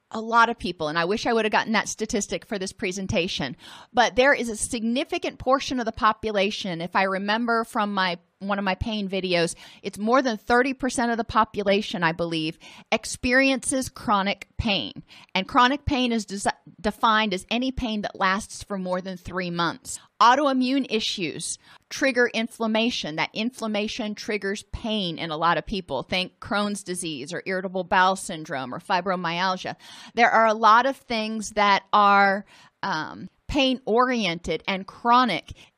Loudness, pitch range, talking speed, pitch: -24 LUFS, 190-235 Hz, 165 wpm, 210 Hz